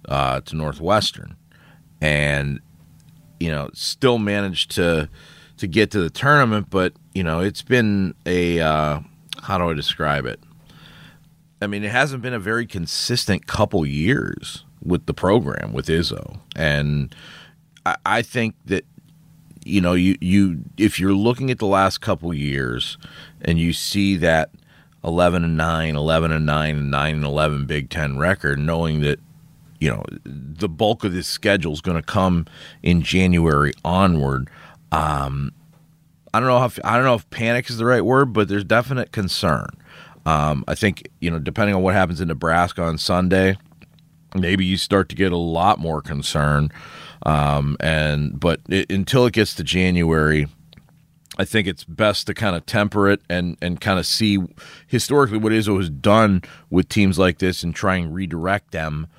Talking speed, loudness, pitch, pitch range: 170 wpm, -20 LUFS, 90 Hz, 80-105 Hz